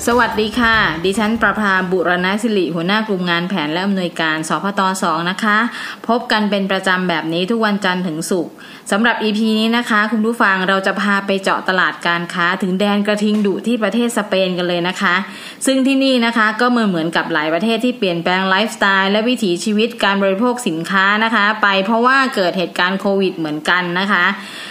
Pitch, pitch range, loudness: 200 Hz, 180-220 Hz, -16 LUFS